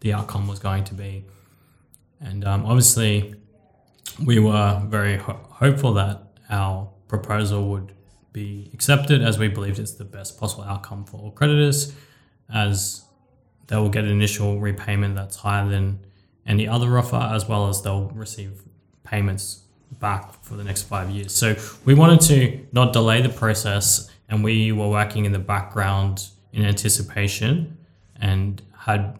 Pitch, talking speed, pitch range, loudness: 105 Hz, 155 wpm, 100-115 Hz, -21 LUFS